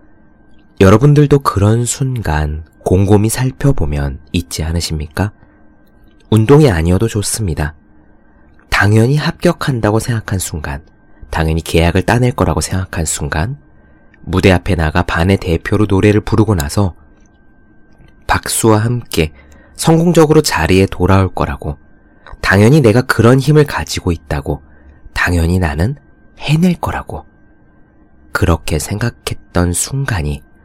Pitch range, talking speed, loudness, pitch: 80-110 Hz, 265 characters per minute, -13 LUFS, 95 Hz